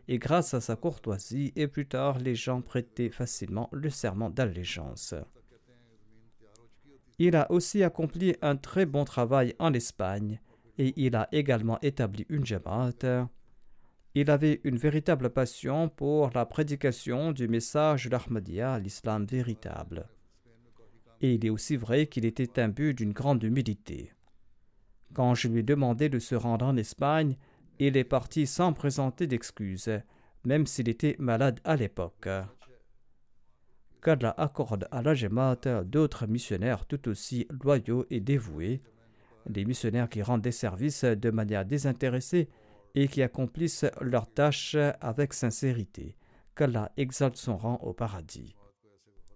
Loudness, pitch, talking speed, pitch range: -29 LUFS, 125 Hz, 135 wpm, 115-140 Hz